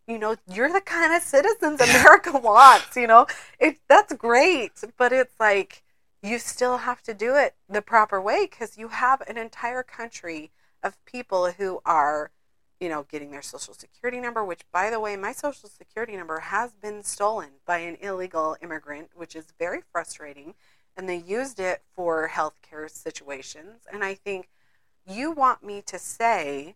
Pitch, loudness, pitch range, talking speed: 210 Hz, -21 LUFS, 175-250 Hz, 175 wpm